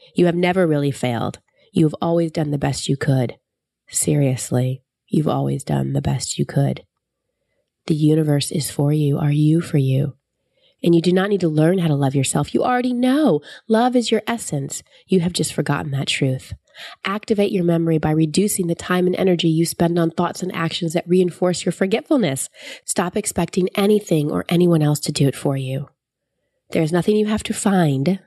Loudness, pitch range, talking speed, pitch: -19 LUFS, 145-185 Hz, 195 wpm, 165 Hz